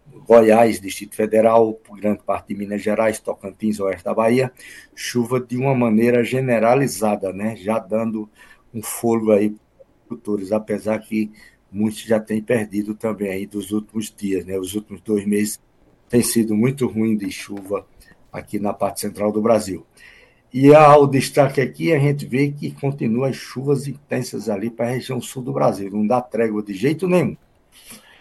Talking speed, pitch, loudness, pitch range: 170 wpm, 110 Hz, -19 LUFS, 105-125 Hz